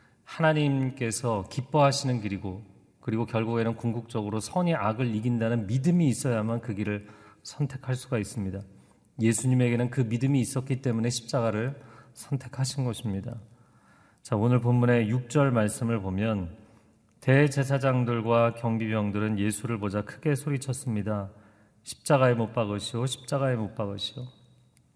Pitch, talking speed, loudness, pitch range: 115 Hz, 320 characters per minute, -27 LUFS, 110-130 Hz